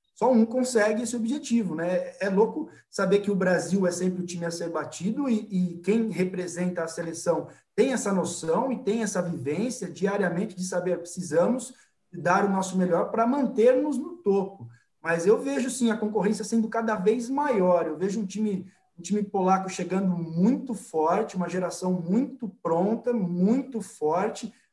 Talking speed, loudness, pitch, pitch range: 170 wpm, -26 LUFS, 195 Hz, 180-230 Hz